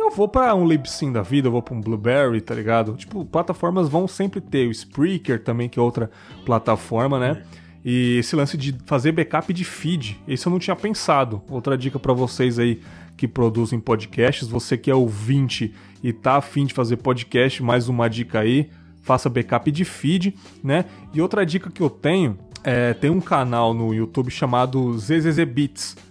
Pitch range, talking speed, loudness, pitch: 115-155 Hz, 185 wpm, -21 LUFS, 130 Hz